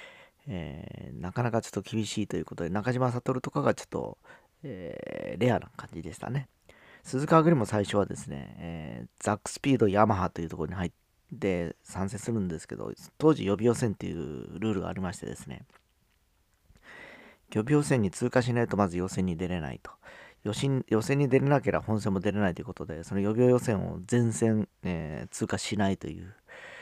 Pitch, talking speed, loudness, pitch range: 105 Hz, 370 characters per minute, -29 LUFS, 90-120 Hz